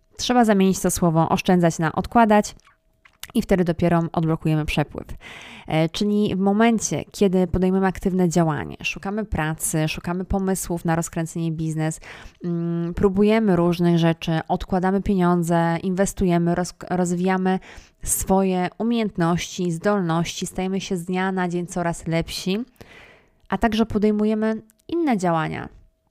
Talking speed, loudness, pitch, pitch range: 115 wpm, -22 LUFS, 180 Hz, 170-195 Hz